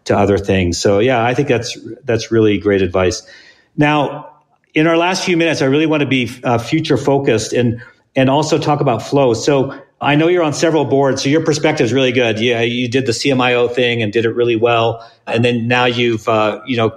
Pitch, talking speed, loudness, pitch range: 125 Hz, 225 wpm, -14 LUFS, 115-145 Hz